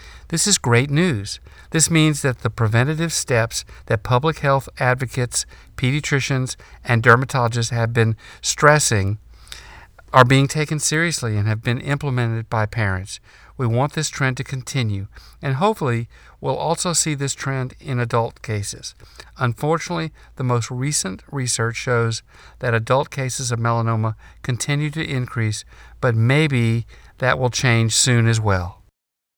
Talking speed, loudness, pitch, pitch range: 140 wpm, -20 LUFS, 125 Hz, 115-140 Hz